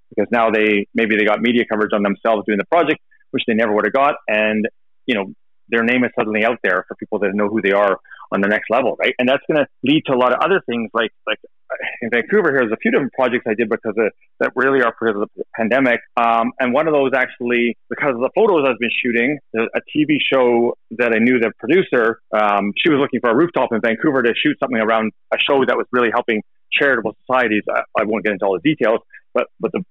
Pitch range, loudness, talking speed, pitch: 105-130 Hz, -17 LUFS, 250 wpm, 115 Hz